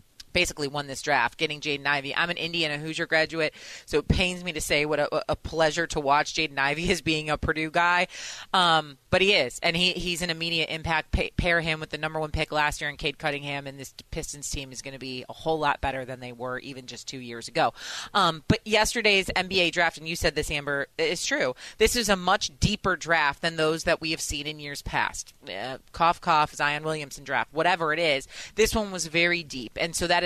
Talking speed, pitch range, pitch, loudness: 235 wpm, 145-170 Hz, 155 Hz, -25 LUFS